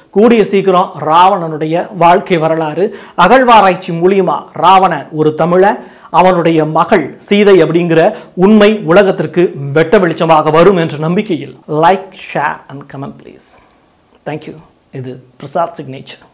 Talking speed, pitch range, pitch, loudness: 110 wpm, 160-195 Hz, 175 Hz, -10 LUFS